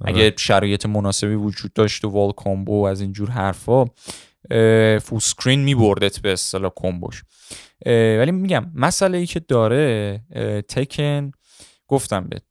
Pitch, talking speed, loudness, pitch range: 110 Hz, 130 wpm, -19 LUFS, 100-130 Hz